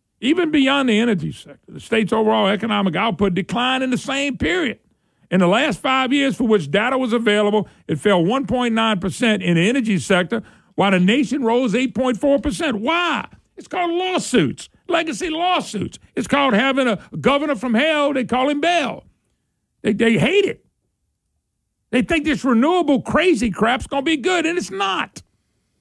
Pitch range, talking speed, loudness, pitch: 215-290 Hz, 165 wpm, -18 LUFS, 255 Hz